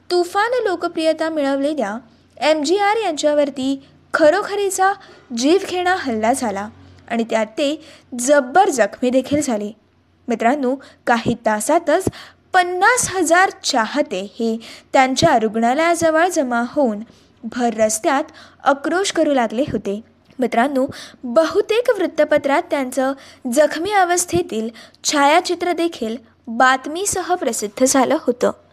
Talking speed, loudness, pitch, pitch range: 100 wpm, -18 LUFS, 295 Hz, 245-350 Hz